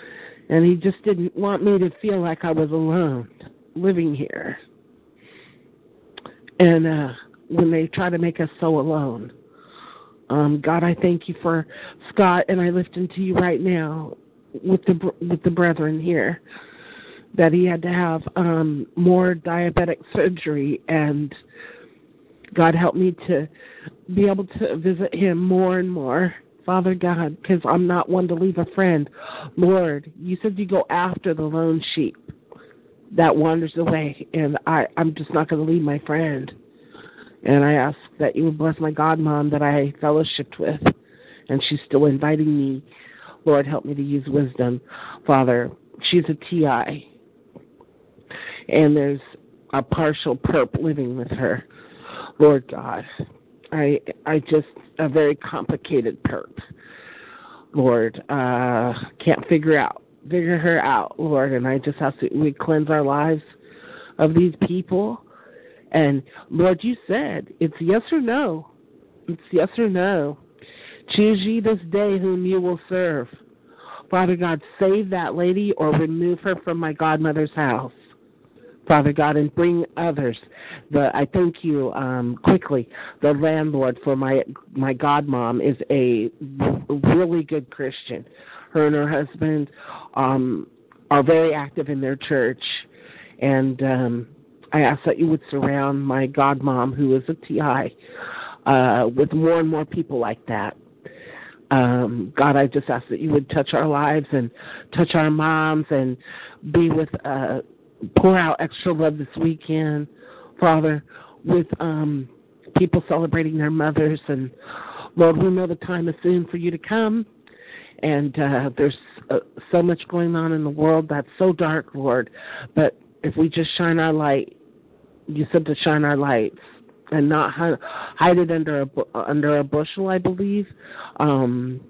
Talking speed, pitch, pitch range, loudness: 155 wpm, 155 Hz, 145-175 Hz, -21 LUFS